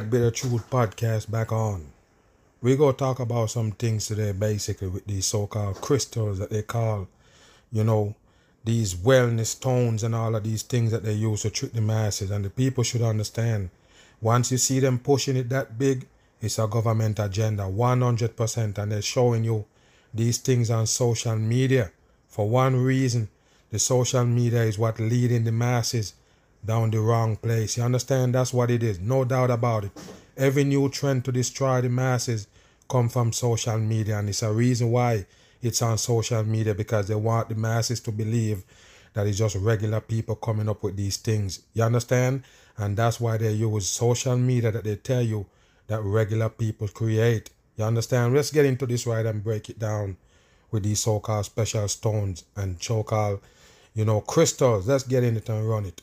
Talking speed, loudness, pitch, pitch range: 185 wpm, -25 LUFS, 115 Hz, 105-125 Hz